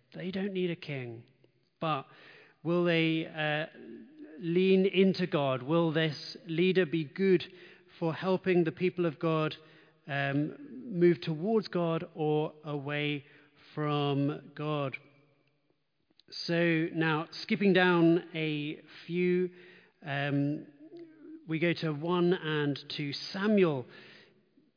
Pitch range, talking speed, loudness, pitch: 150-180 Hz, 110 wpm, -31 LUFS, 160 Hz